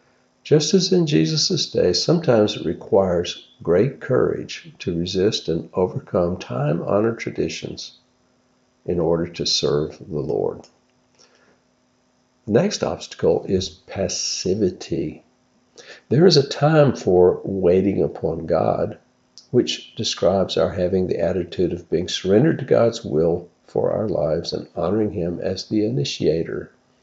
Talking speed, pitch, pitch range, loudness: 125 wpm, 95 Hz, 85-125 Hz, -21 LUFS